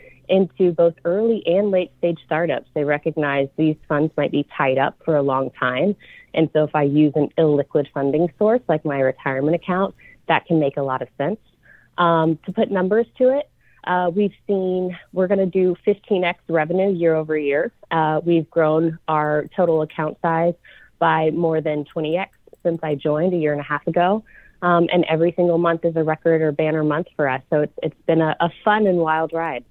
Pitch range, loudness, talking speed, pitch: 150-180 Hz, -20 LUFS, 200 wpm, 165 Hz